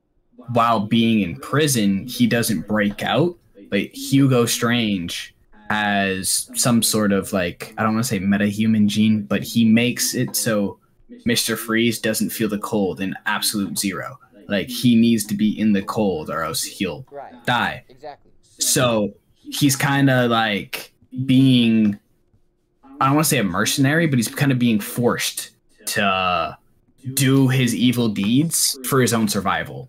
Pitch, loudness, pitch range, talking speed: 115 Hz, -19 LUFS, 105-130 Hz, 150 wpm